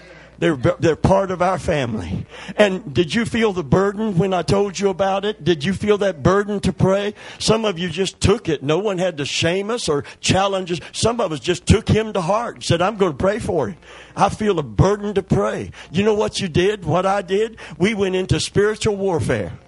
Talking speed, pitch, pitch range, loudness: 230 wpm, 190 Hz, 175-205 Hz, -19 LUFS